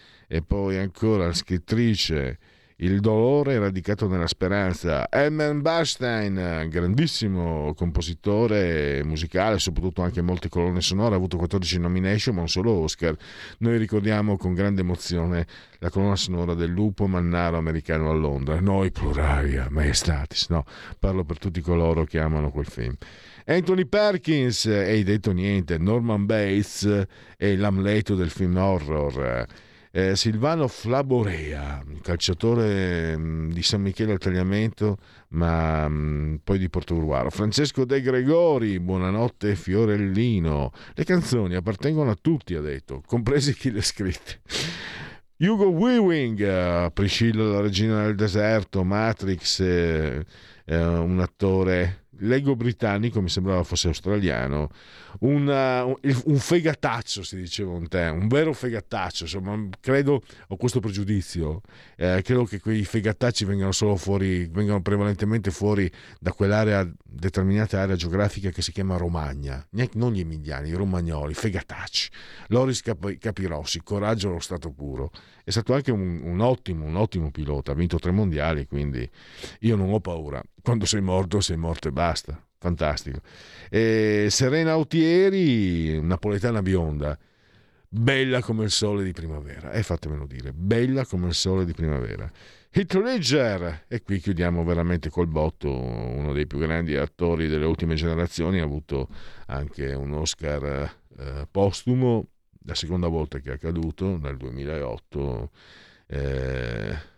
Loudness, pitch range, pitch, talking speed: -24 LUFS, 80-110 Hz, 95 Hz, 135 wpm